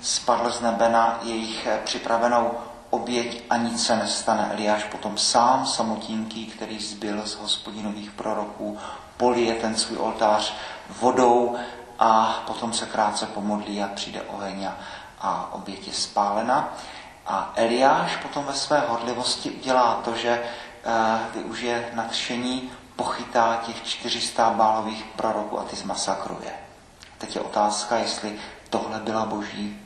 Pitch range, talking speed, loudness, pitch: 105-120 Hz, 125 wpm, -24 LUFS, 115 Hz